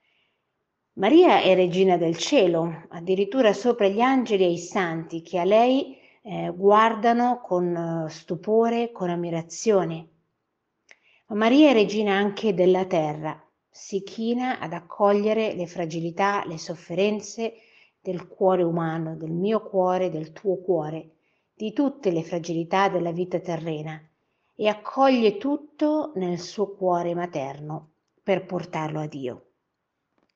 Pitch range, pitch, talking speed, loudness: 165-210 Hz, 185 Hz, 125 wpm, -23 LUFS